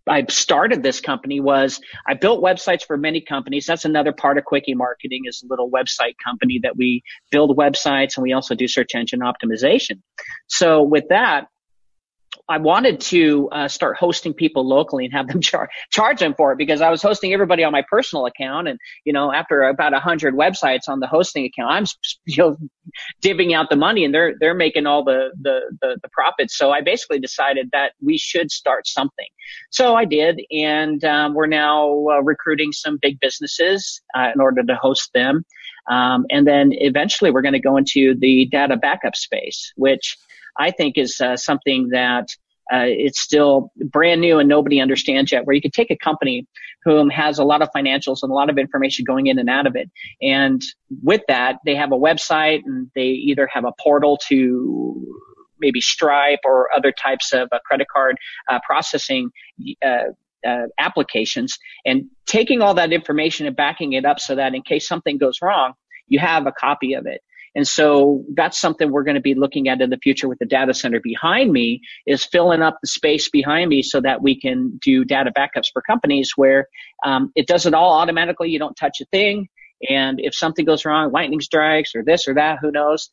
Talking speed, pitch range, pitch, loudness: 200 wpm, 135-170 Hz, 150 Hz, -17 LUFS